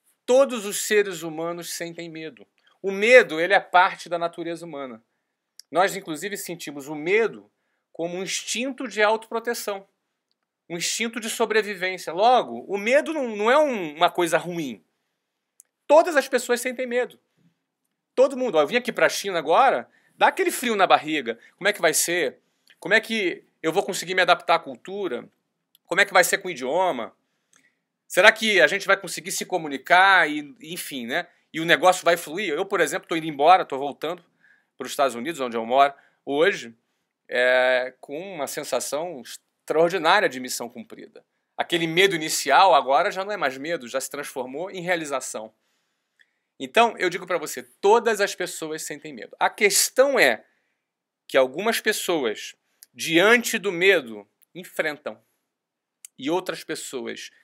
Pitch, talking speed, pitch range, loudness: 185 Hz, 165 wpm, 155-225 Hz, -22 LUFS